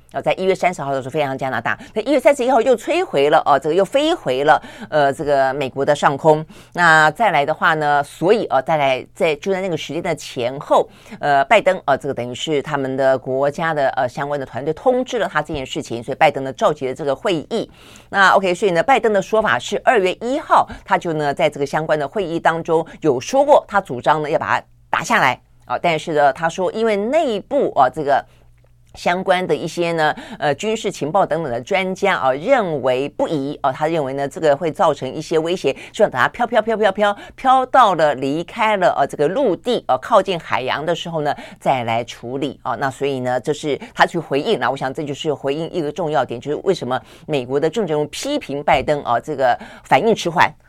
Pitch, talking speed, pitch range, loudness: 155 Hz, 330 characters per minute, 140-190 Hz, -18 LUFS